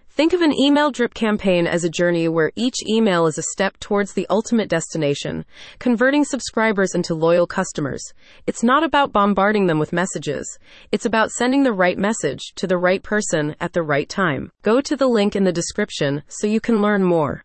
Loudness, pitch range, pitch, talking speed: -19 LUFS, 175-230 Hz, 200 Hz, 195 wpm